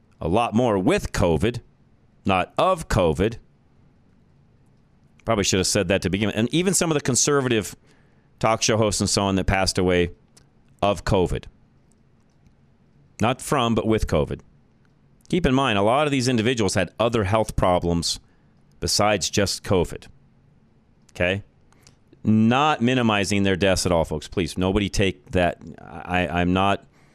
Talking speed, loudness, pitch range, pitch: 150 wpm, -22 LUFS, 90-115 Hz, 100 Hz